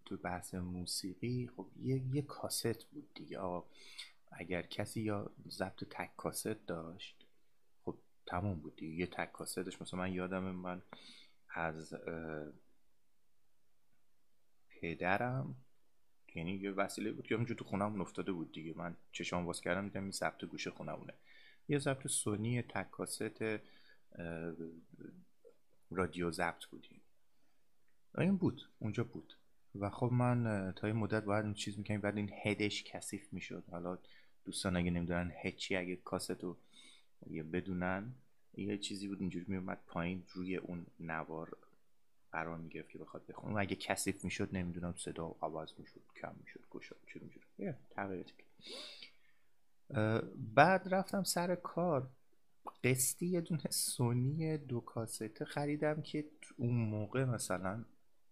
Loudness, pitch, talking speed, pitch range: -40 LUFS, 100 Hz, 135 wpm, 90-120 Hz